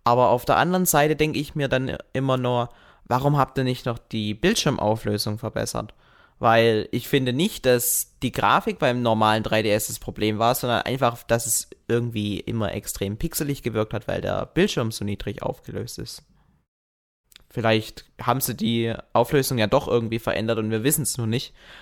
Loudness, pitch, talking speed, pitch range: -23 LUFS, 120 Hz, 175 wpm, 110-130 Hz